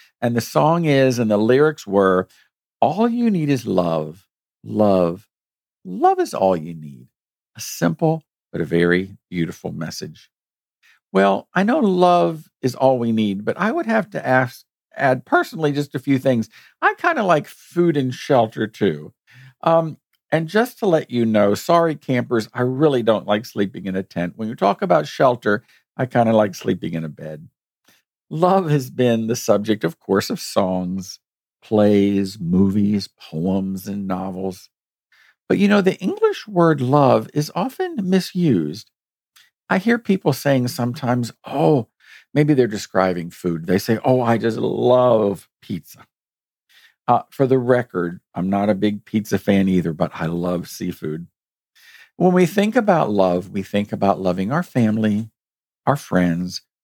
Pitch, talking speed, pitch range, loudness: 115 Hz, 160 wpm, 95-150 Hz, -19 LUFS